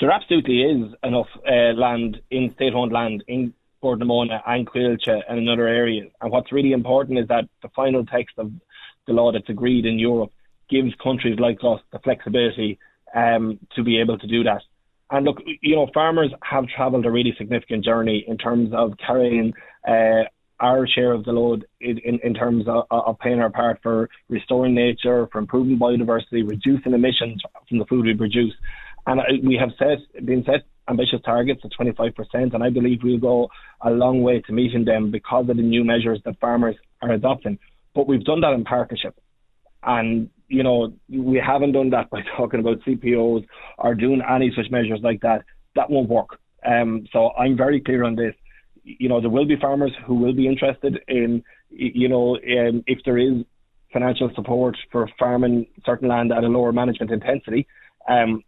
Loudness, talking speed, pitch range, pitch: -21 LUFS, 190 wpm, 115-125 Hz, 120 Hz